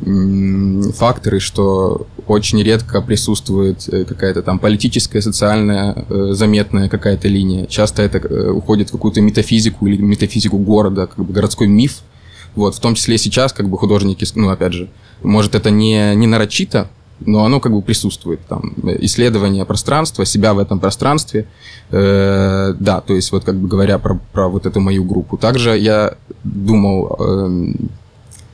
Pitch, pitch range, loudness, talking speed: 105 Hz, 95-110 Hz, -14 LUFS, 145 wpm